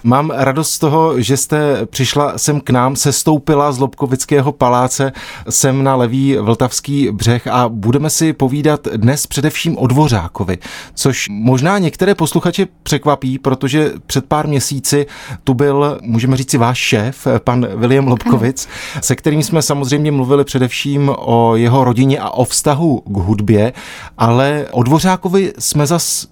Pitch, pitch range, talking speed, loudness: 135 Hz, 125-150 Hz, 145 wpm, -14 LUFS